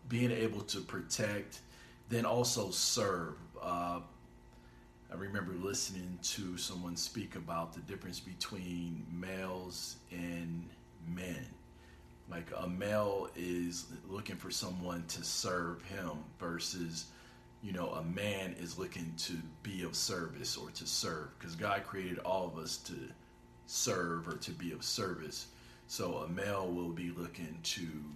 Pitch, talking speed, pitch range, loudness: 85 Hz, 140 wpm, 85-95 Hz, -39 LUFS